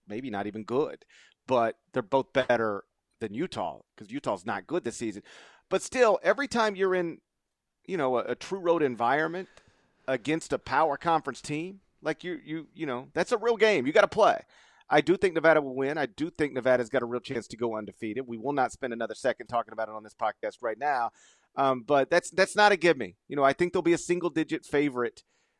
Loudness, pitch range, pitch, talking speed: -28 LUFS, 125-175 Hz, 150 Hz, 225 wpm